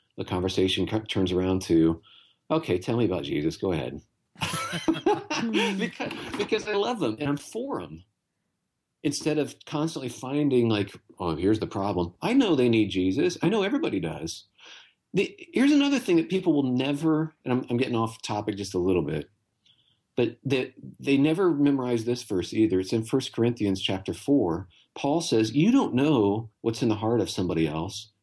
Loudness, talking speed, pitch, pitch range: -26 LUFS, 175 wpm, 120 Hz, 100-150 Hz